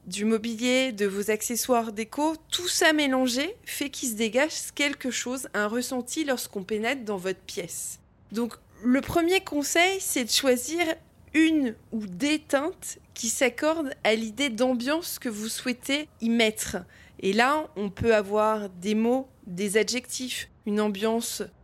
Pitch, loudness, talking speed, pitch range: 250 Hz, -26 LUFS, 150 wpm, 220-290 Hz